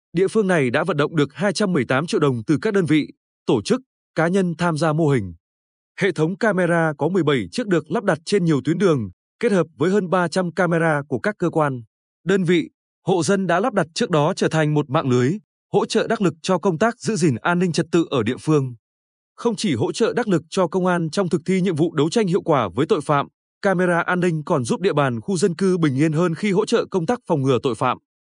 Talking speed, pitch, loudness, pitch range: 250 wpm, 175 Hz, -20 LUFS, 150-195 Hz